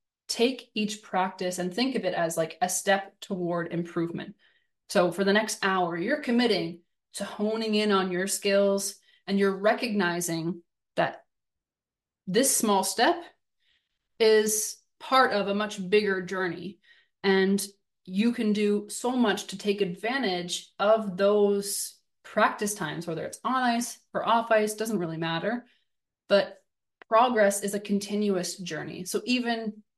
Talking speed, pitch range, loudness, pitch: 140 wpm, 185-220 Hz, -27 LUFS, 200 Hz